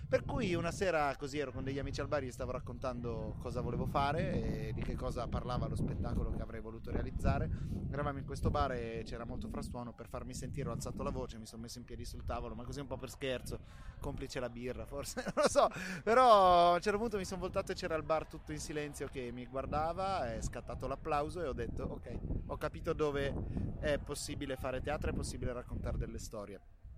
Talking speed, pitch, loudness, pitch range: 225 wpm, 130 Hz, -37 LUFS, 120-150 Hz